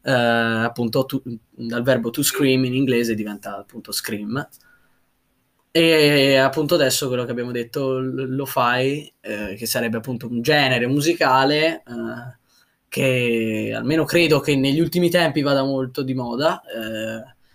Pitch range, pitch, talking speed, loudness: 115-140 Hz, 130 Hz, 140 wpm, -20 LUFS